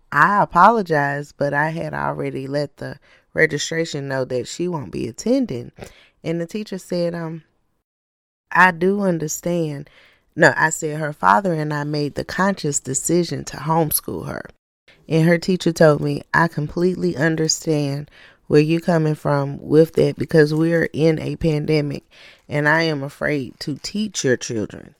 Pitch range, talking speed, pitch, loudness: 145-170 Hz, 155 wpm, 155 Hz, -19 LUFS